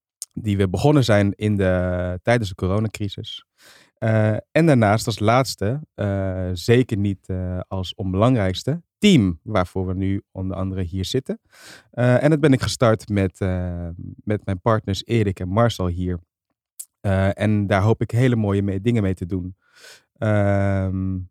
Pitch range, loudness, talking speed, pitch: 95-115 Hz, -21 LUFS, 160 wpm, 100 Hz